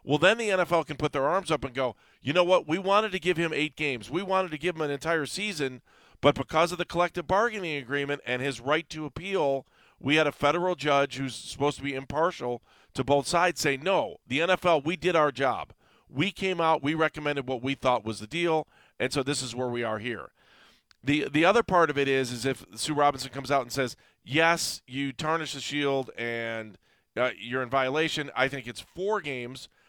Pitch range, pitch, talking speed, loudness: 135-165 Hz, 145 Hz, 225 wpm, -27 LUFS